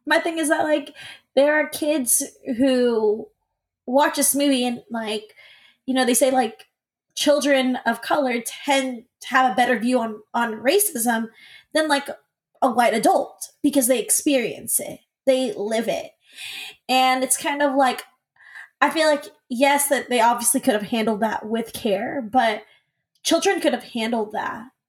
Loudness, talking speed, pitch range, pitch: -21 LUFS, 160 wpm, 235-290 Hz, 260 Hz